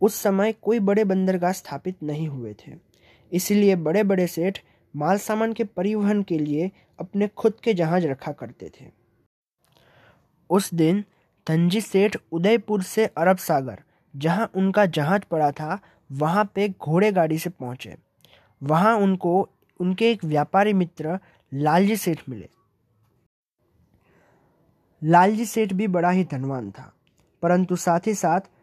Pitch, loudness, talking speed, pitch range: 180 Hz, -22 LUFS, 135 wpm, 155-205 Hz